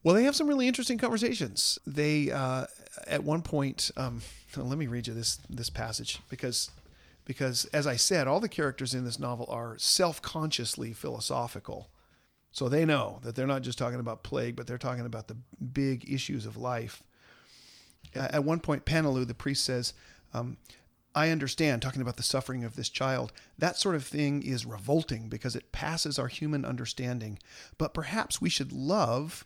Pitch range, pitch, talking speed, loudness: 120-150 Hz, 130 Hz, 180 wpm, -31 LUFS